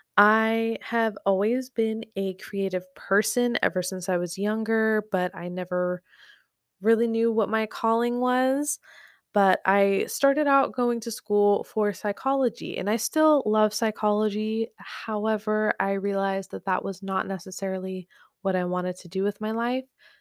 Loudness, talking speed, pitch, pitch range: -25 LUFS, 150 wpm, 215 Hz, 195-225 Hz